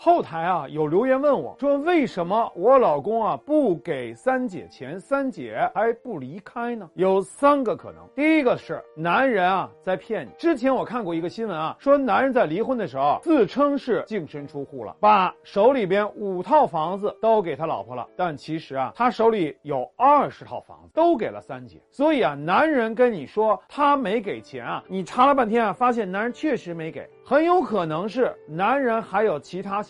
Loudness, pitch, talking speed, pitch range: -22 LUFS, 225 Hz, 280 characters per minute, 185-275 Hz